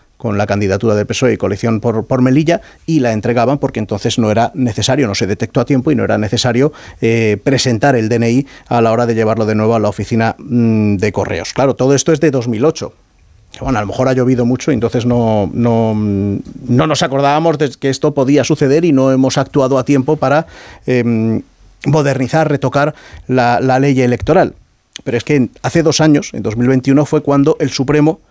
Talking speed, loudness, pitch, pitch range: 200 wpm, -13 LUFS, 125 Hz, 110-140 Hz